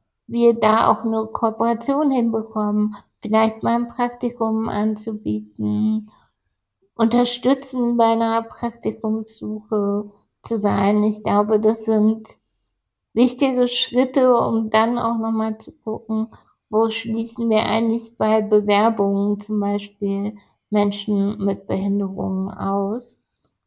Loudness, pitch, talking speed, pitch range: -20 LUFS, 220 Hz, 105 wpm, 205-230 Hz